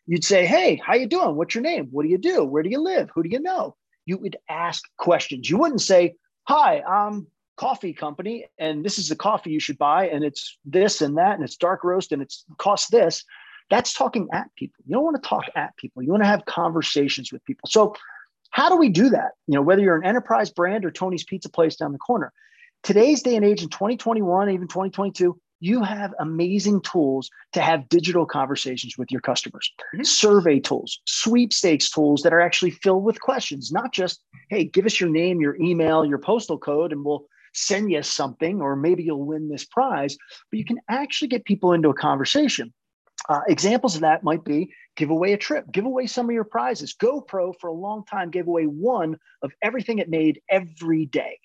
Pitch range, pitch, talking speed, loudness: 160-225 Hz, 185 Hz, 210 wpm, -22 LUFS